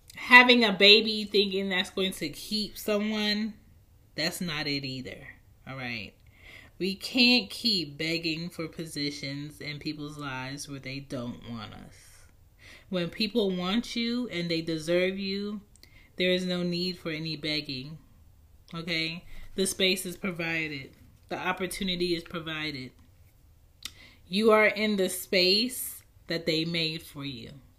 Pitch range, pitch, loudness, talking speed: 135-190 Hz, 165 Hz, -27 LUFS, 135 wpm